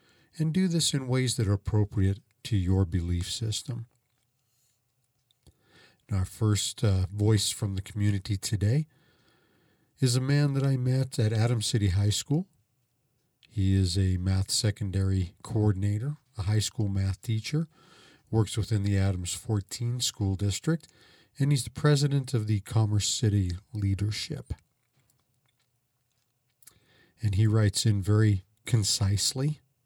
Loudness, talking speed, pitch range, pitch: -28 LUFS, 130 wpm, 100-130 Hz, 110 Hz